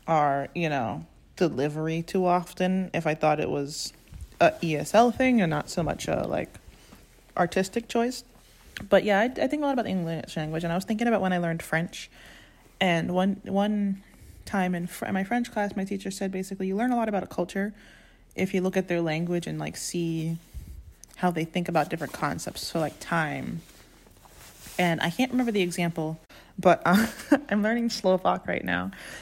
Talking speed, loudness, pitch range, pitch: 195 wpm, -27 LUFS, 160-200 Hz, 180 Hz